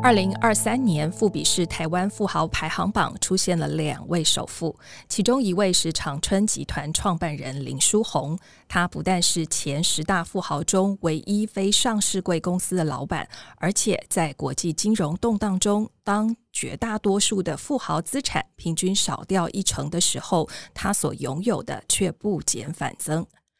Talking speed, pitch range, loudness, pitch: 245 characters per minute, 160-205 Hz, -23 LUFS, 185 Hz